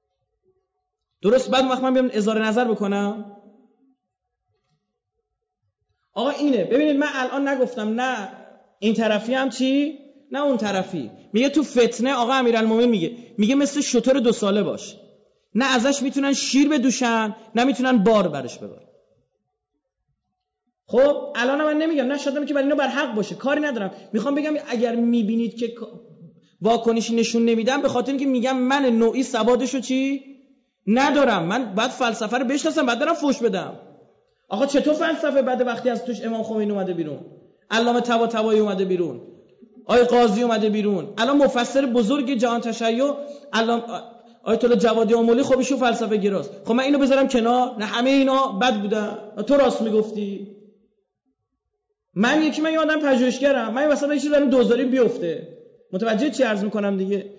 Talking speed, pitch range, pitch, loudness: 155 wpm, 220-275 Hz, 245 Hz, -21 LUFS